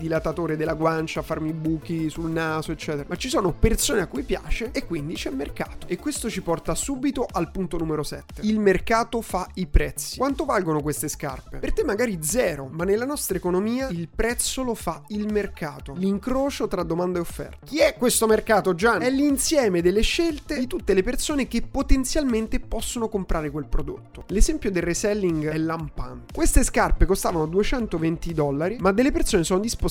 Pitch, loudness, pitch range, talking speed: 195 Hz, -24 LUFS, 165-245 Hz, 185 wpm